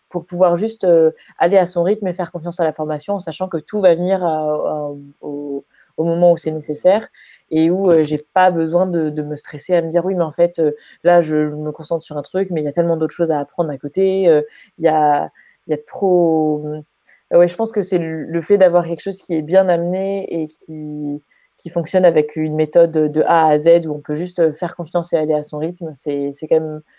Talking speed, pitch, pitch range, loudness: 240 wpm, 165 Hz, 155-175 Hz, -17 LUFS